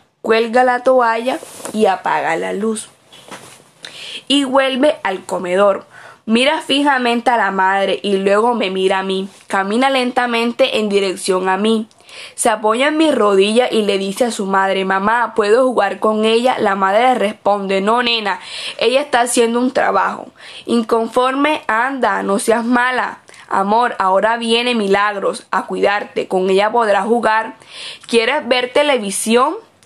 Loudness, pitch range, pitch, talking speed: -15 LUFS, 200-250 Hz, 225 Hz, 145 wpm